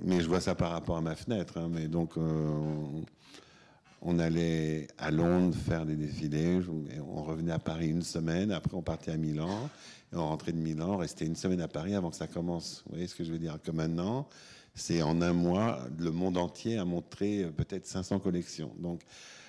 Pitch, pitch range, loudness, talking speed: 85 Hz, 80-90 Hz, -33 LUFS, 205 wpm